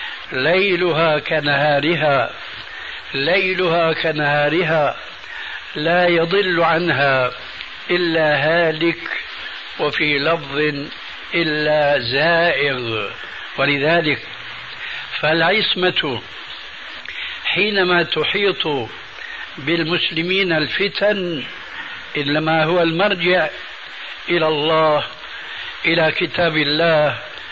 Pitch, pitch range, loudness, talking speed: 165 Hz, 150-175 Hz, -17 LUFS, 60 wpm